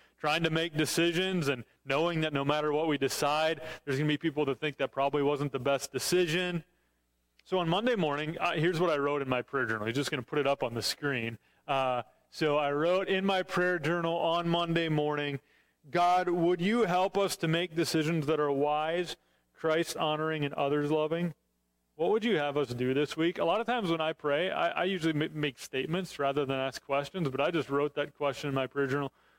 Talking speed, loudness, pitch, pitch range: 225 wpm, -30 LUFS, 150 Hz, 140-170 Hz